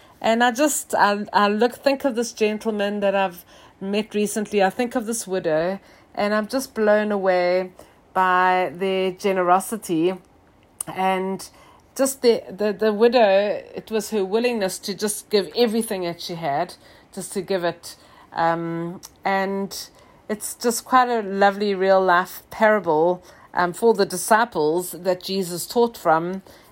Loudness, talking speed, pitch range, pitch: -21 LUFS, 150 wpm, 185-220 Hz, 195 Hz